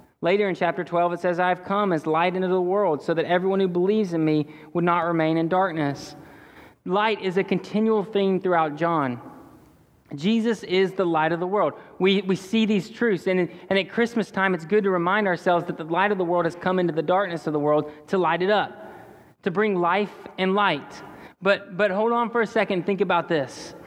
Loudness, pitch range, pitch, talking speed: -23 LUFS, 170-200 Hz, 185 Hz, 220 wpm